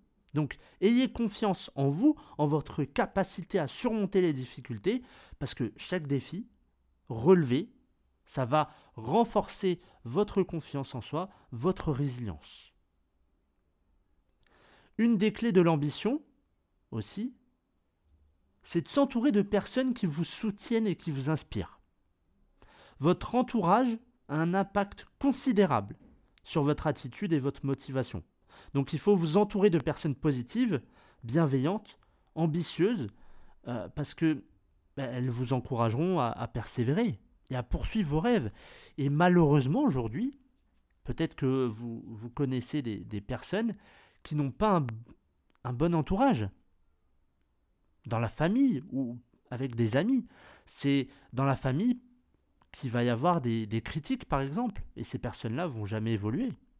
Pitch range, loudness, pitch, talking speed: 120-200 Hz, -31 LUFS, 150 Hz, 130 wpm